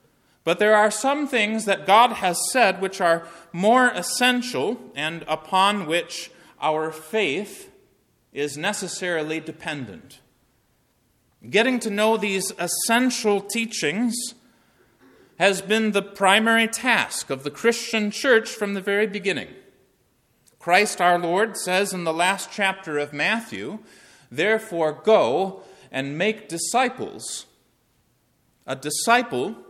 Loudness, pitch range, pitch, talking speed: -22 LUFS, 170-225 Hz, 200 Hz, 115 wpm